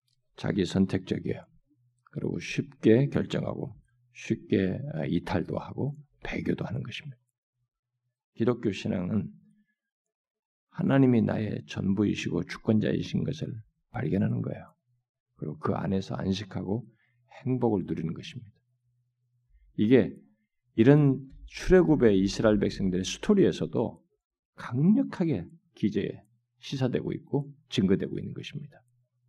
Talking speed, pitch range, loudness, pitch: 265 characters per minute, 110-145 Hz, -28 LUFS, 125 Hz